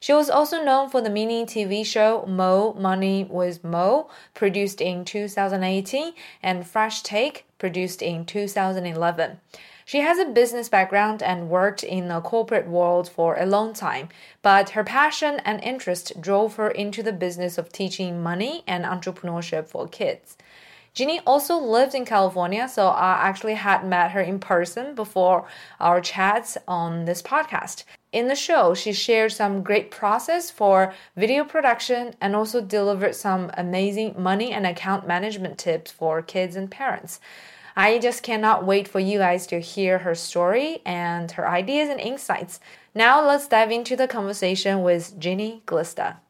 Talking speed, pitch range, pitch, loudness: 160 wpm, 180-230 Hz, 195 Hz, -22 LUFS